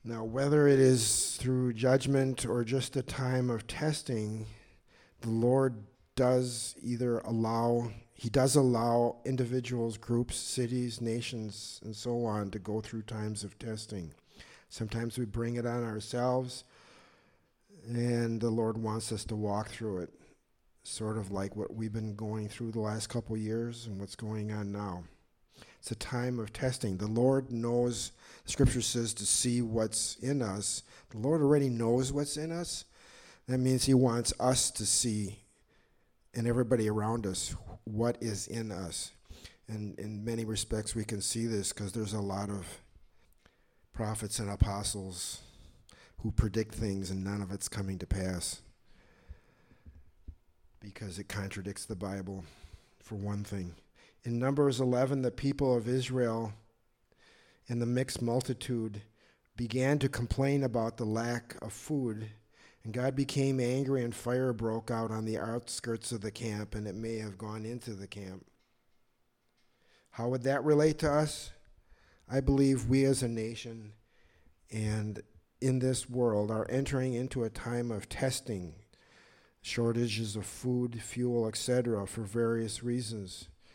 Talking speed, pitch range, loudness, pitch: 150 wpm, 105-125 Hz, -33 LUFS, 115 Hz